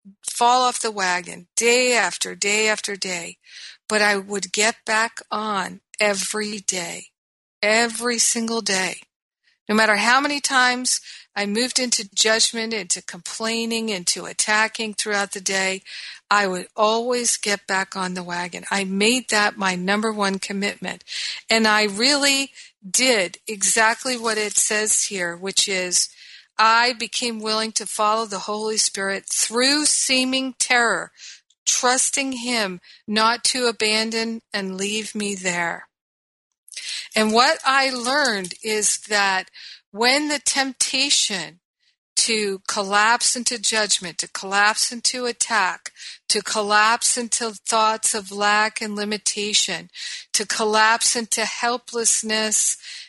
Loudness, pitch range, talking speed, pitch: -20 LUFS, 200-235 Hz, 125 wpm, 220 Hz